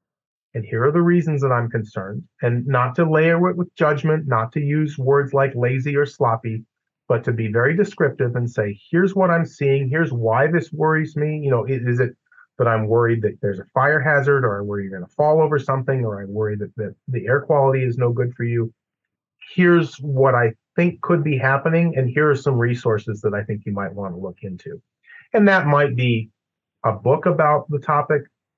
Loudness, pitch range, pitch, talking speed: -20 LUFS, 115-155 Hz, 135 Hz, 215 wpm